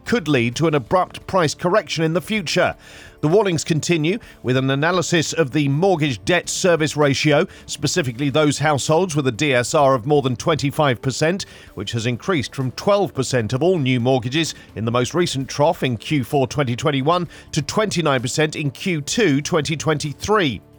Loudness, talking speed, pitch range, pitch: -19 LUFS, 155 wpm, 130-170 Hz, 150 Hz